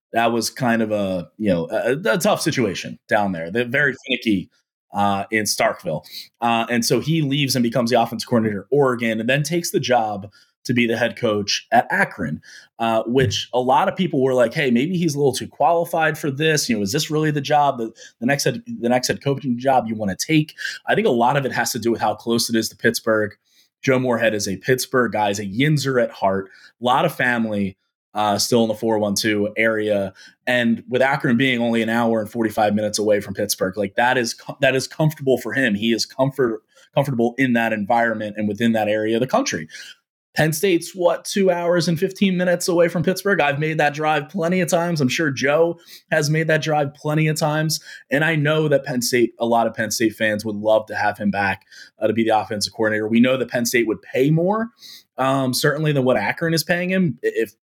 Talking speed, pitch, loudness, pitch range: 235 wpm, 125 Hz, -20 LUFS, 110-150 Hz